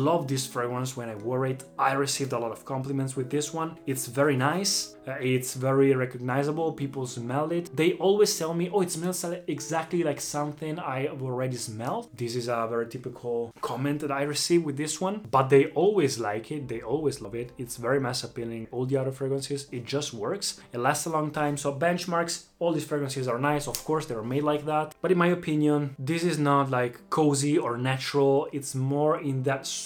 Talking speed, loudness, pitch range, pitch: 210 wpm, -28 LUFS, 125-155 Hz, 140 Hz